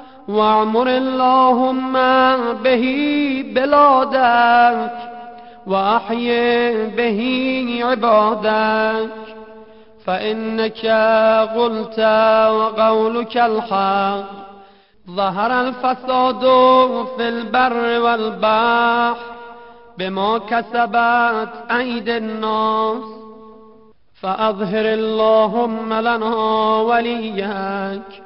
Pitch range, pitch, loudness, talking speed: 220-240 Hz, 230 Hz, -16 LUFS, 50 wpm